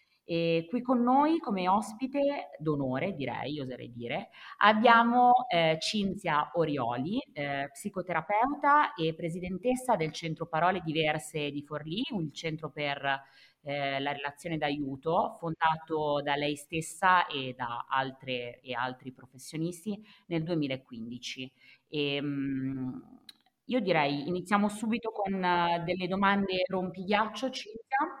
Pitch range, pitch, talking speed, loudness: 145-205 Hz, 165 Hz, 115 wpm, -30 LUFS